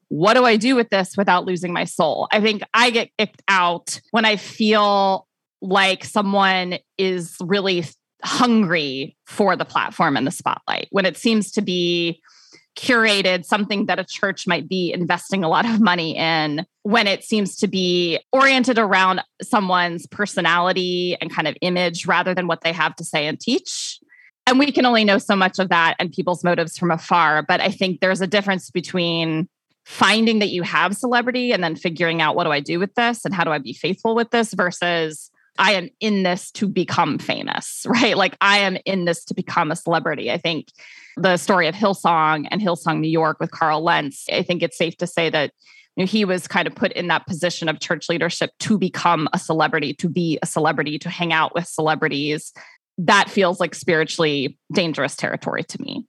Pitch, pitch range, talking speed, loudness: 180 Hz, 165-200 Hz, 200 wpm, -19 LUFS